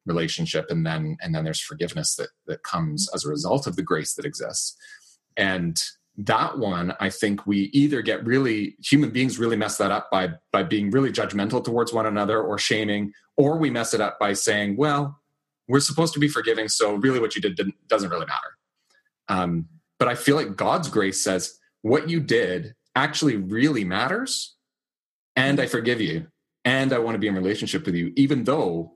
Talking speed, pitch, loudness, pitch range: 195 wpm, 115 Hz, -23 LUFS, 100-145 Hz